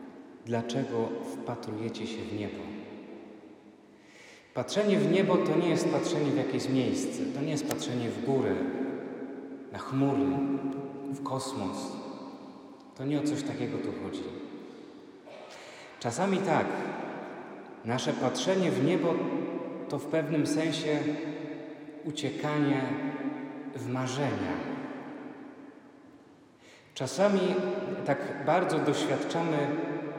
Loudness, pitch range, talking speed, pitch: -31 LUFS, 135-165 Hz, 95 wpm, 150 Hz